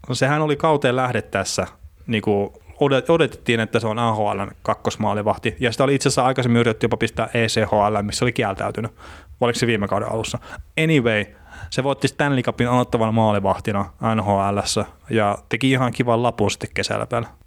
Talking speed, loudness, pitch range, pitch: 160 wpm, -20 LUFS, 105-125 Hz, 115 Hz